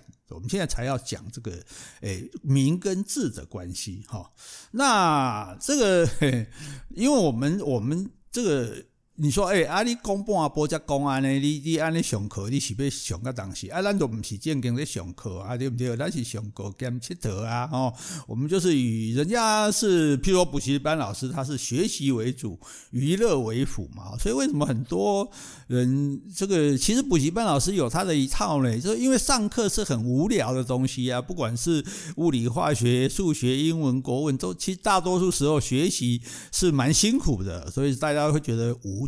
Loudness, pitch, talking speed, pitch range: -25 LUFS, 140 Hz, 270 characters per minute, 125-180 Hz